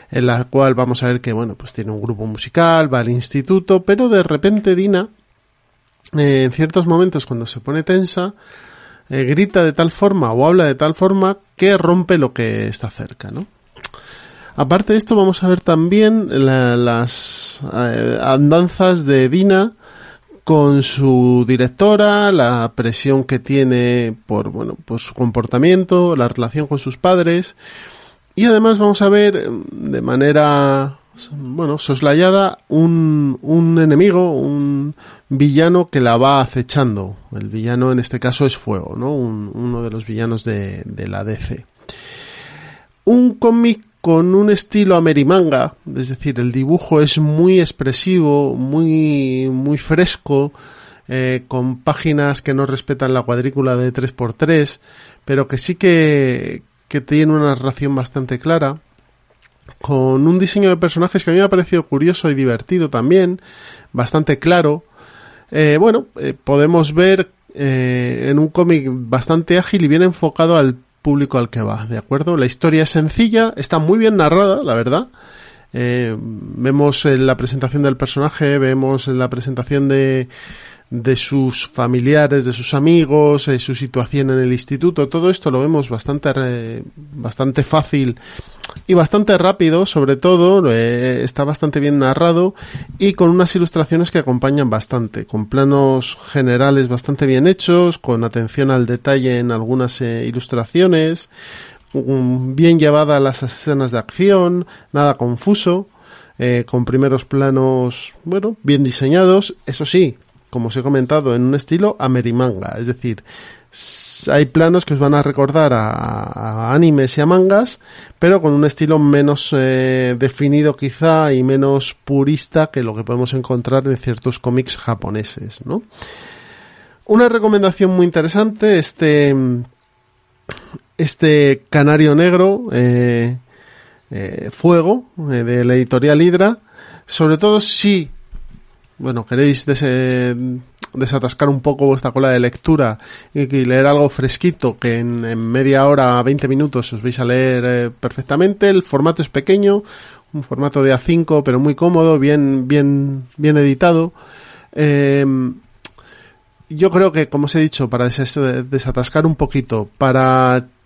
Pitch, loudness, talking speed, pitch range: 140 Hz, -14 LUFS, 145 wpm, 125-165 Hz